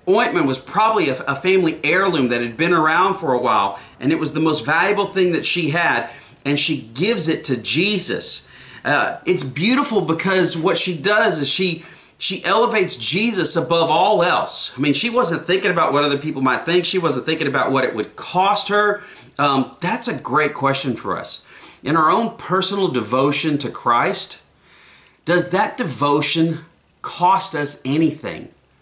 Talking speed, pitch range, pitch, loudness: 175 wpm, 145-190 Hz, 165 Hz, -18 LUFS